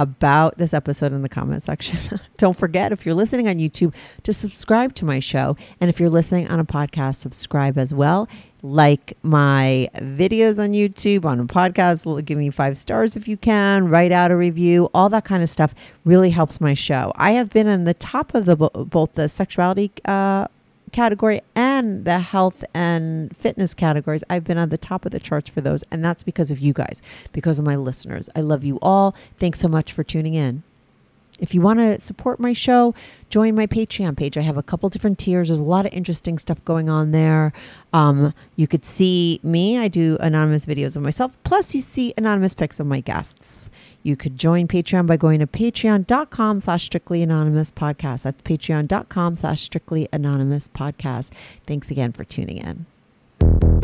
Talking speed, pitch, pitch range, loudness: 195 wpm, 165 Hz, 150-195 Hz, -19 LUFS